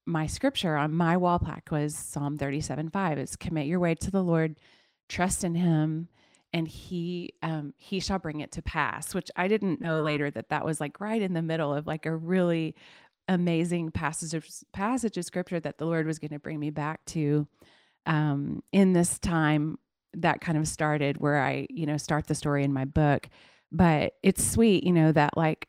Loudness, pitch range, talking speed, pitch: -28 LUFS, 150-175 Hz, 205 wpm, 160 Hz